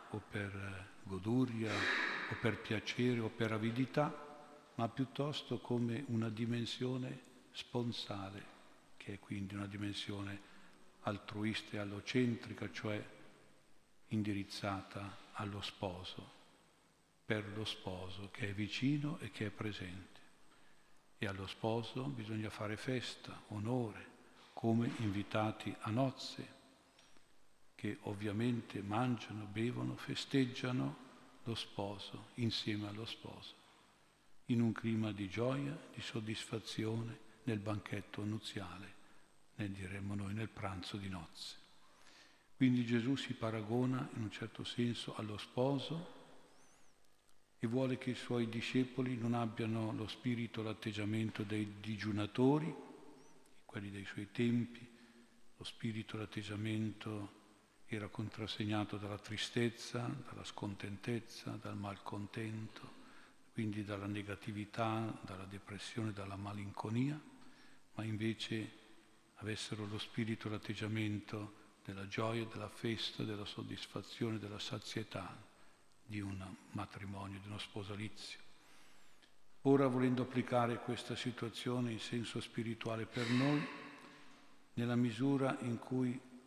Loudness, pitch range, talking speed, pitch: -41 LUFS, 105-120 Hz, 105 wpm, 110 Hz